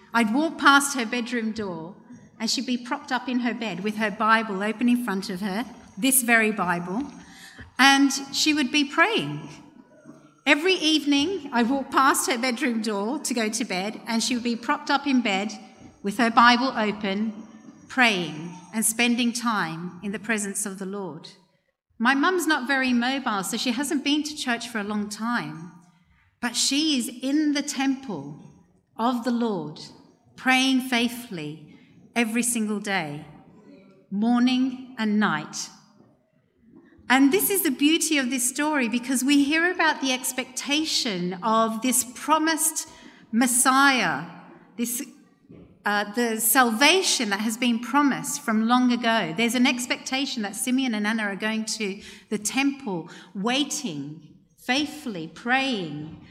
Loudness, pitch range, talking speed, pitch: -23 LUFS, 210-270 Hz, 150 wpm, 240 Hz